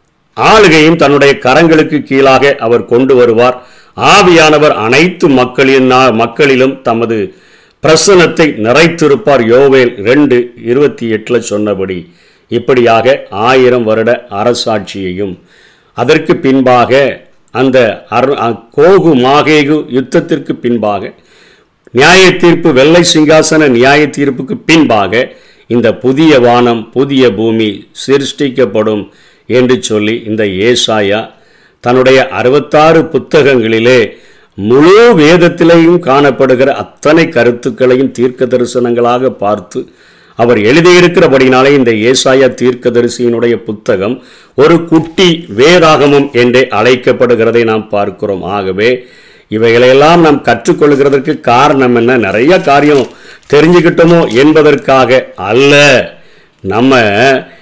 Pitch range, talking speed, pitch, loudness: 120-155 Hz, 85 wpm, 130 Hz, -7 LUFS